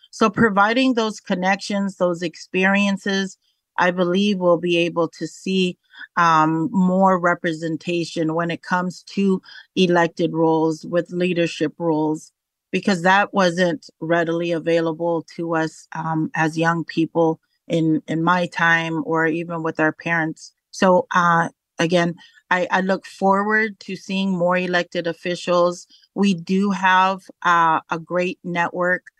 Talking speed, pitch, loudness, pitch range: 130 wpm, 175 Hz, -20 LUFS, 165-190 Hz